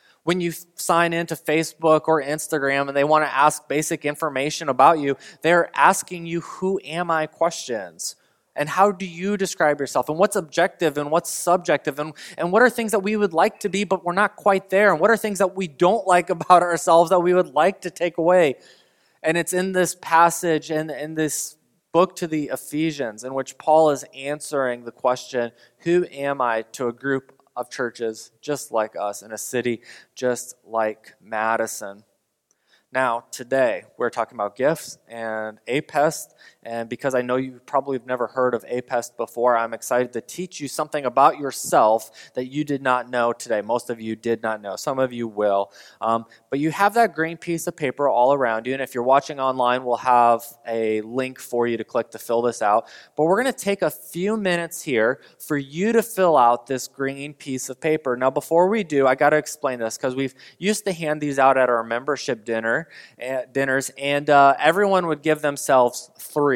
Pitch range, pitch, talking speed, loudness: 125-170 Hz, 145 Hz, 205 wpm, -22 LUFS